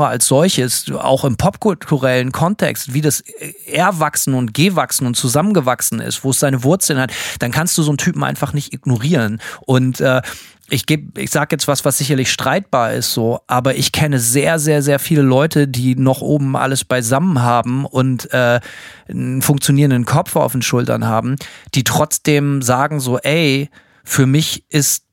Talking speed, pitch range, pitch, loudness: 170 wpm, 125-150 Hz, 140 Hz, -15 LUFS